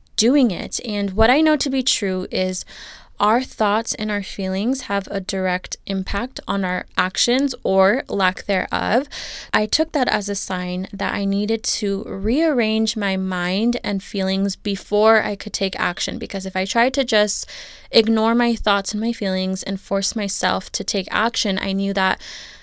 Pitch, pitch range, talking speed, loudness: 205 Hz, 195-230 Hz, 175 wpm, -20 LUFS